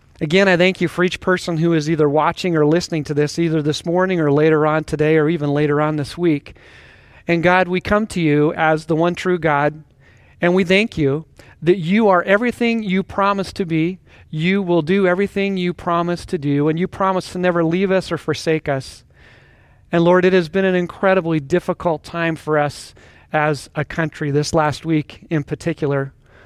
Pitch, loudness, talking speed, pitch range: 170 Hz, -18 LUFS, 200 wpm, 150-185 Hz